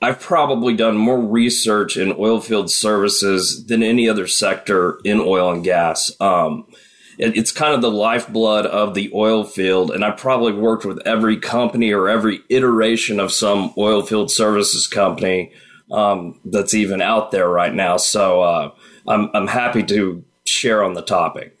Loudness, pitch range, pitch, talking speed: -17 LUFS, 100-115 Hz, 105 Hz, 170 wpm